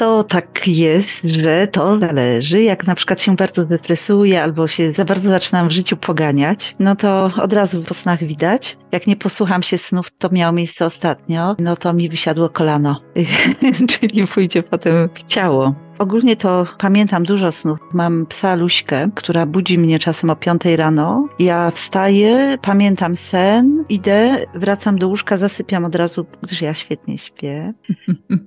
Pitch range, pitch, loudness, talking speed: 170-200 Hz, 180 Hz, -15 LUFS, 160 wpm